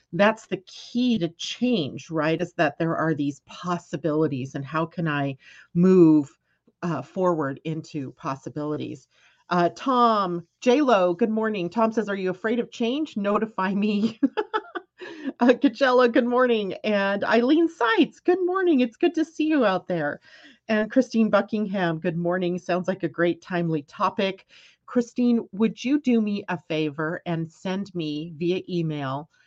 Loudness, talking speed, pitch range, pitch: -24 LUFS, 150 wpm, 165-235 Hz, 190 Hz